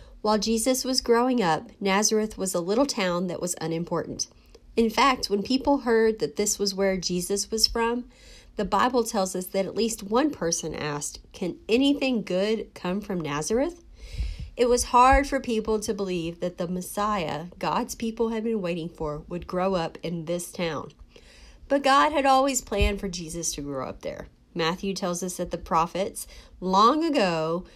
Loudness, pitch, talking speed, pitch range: -25 LUFS, 200 Hz, 175 wpm, 175-235 Hz